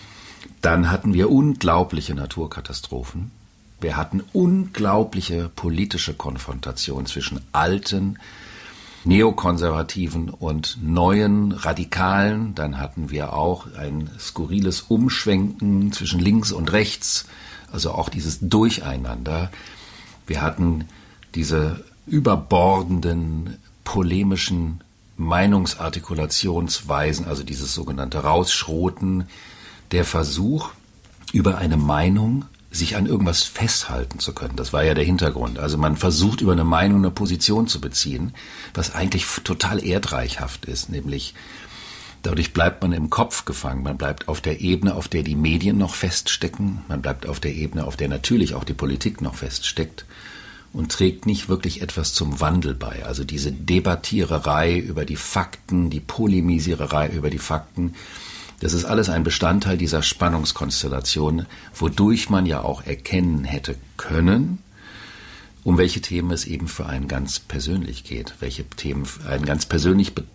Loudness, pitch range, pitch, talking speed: -22 LUFS, 75-95 Hz, 85 Hz, 130 wpm